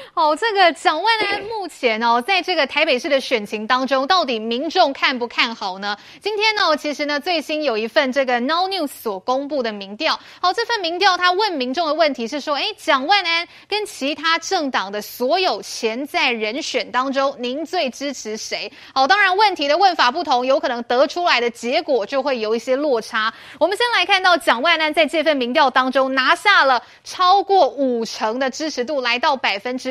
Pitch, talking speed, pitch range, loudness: 295 Hz, 305 characters per minute, 250-350 Hz, -18 LUFS